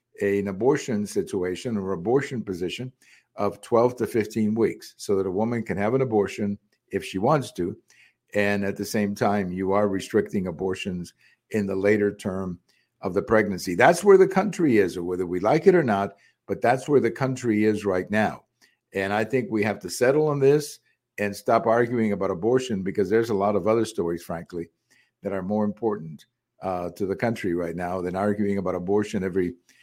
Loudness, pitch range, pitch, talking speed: -24 LUFS, 95-115 Hz, 105 Hz, 195 wpm